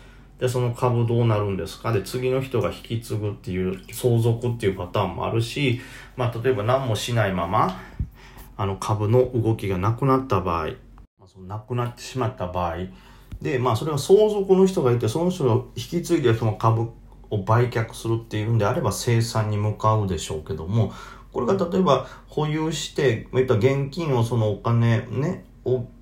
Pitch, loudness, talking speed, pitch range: 120 Hz, -23 LUFS, 365 characters per minute, 105-125 Hz